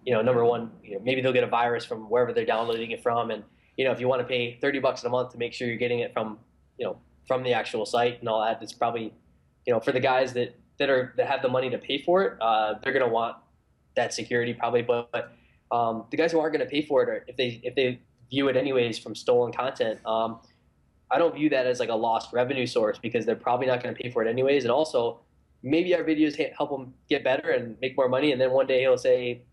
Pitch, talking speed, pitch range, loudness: 125 Hz, 265 wpm, 120-140 Hz, -26 LUFS